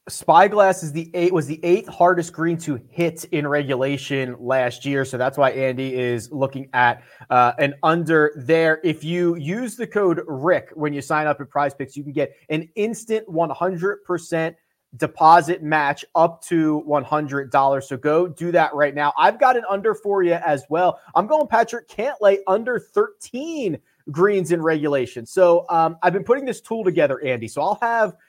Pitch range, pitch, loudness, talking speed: 145-190 Hz, 165 Hz, -20 LUFS, 190 wpm